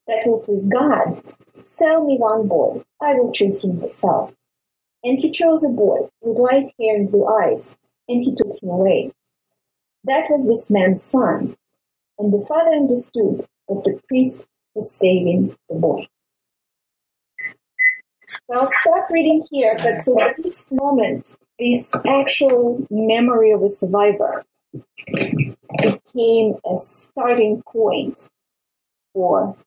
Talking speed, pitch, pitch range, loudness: 135 wpm, 240 Hz, 210-275 Hz, -17 LUFS